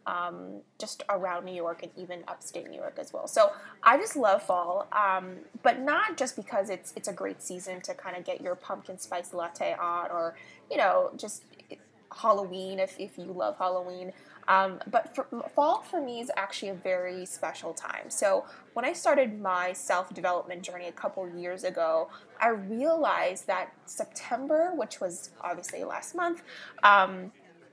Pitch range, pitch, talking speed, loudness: 180-245 Hz, 190 Hz, 175 wpm, -30 LUFS